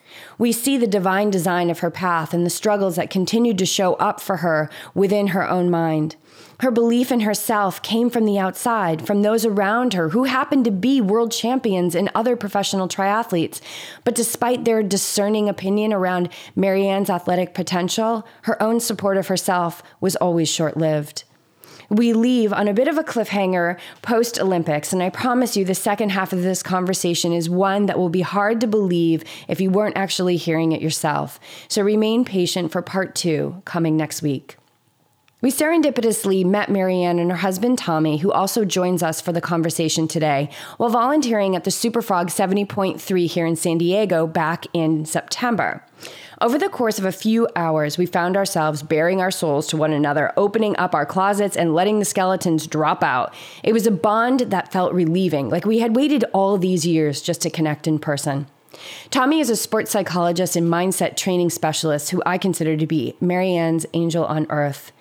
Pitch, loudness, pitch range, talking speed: 185 Hz, -20 LUFS, 170-215 Hz, 185 wpm